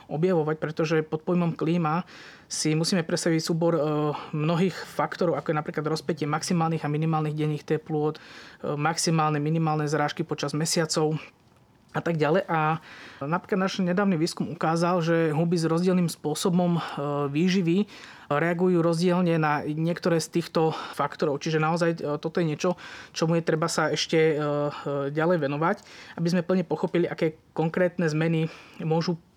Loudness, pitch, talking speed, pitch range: -26 LUFS, 165 Hz, 135 wpm, 155-175 Hz